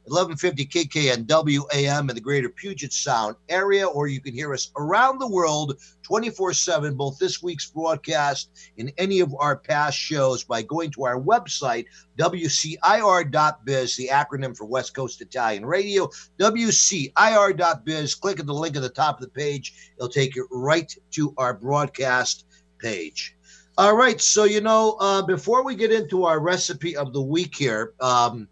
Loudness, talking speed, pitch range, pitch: -22 LUFS, 165 wpm, 135-180 Hz, 150 Hz